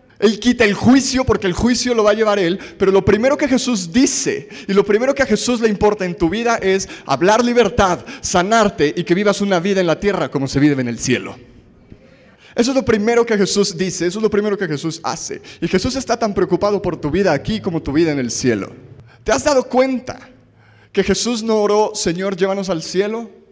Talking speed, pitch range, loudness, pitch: 225 wpm, 175-225 Hz, -16 LUFS, 200 Hz